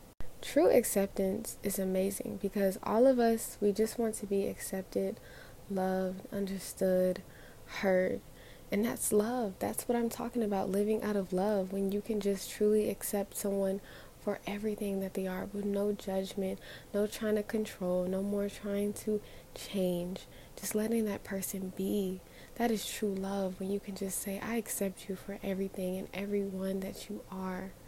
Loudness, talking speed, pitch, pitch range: -34 LUFS, 165 wpm, 200 Hz, 190-210 Hz